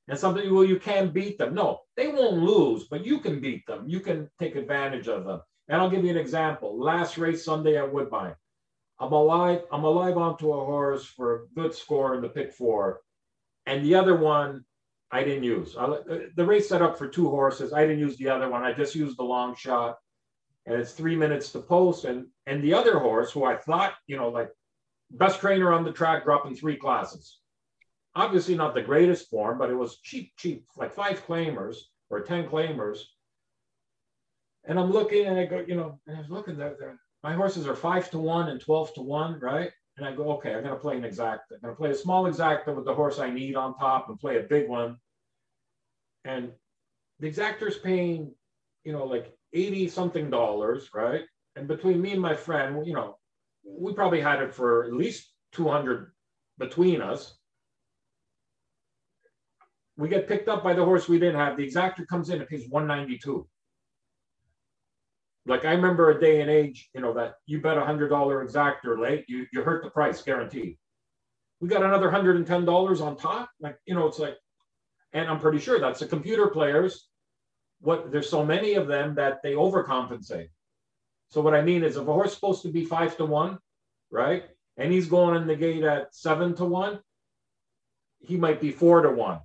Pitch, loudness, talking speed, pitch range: 155 Hz, -26 LUFS, 200 wpm, 135-175 Hz